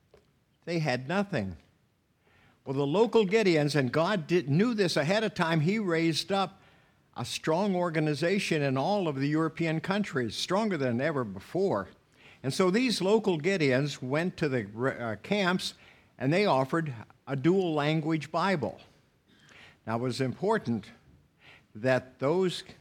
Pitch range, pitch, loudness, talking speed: 130-185 Hz, 160 Hz, -29 LUFS, 140 wpm